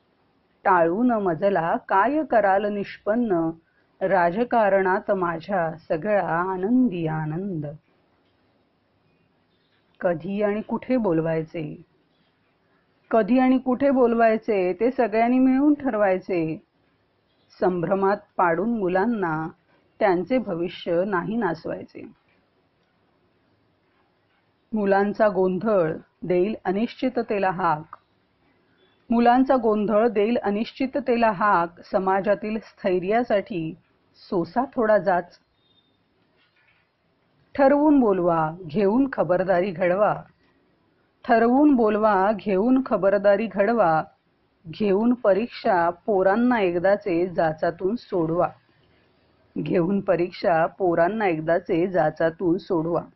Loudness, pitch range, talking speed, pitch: -22 LUFS, 175-225 Hz, 75 wpm, 195 Hz